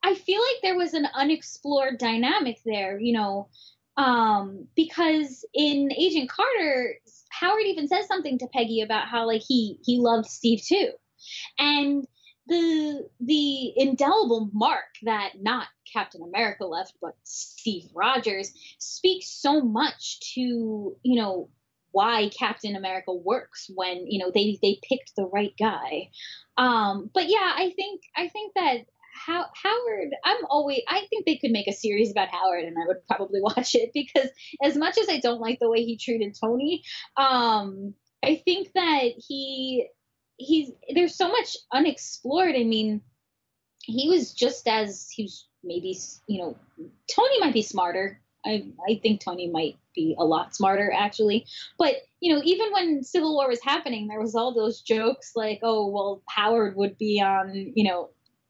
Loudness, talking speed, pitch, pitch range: -25 LUFS, 165 wpm, 245 Hz, 210-315 Hz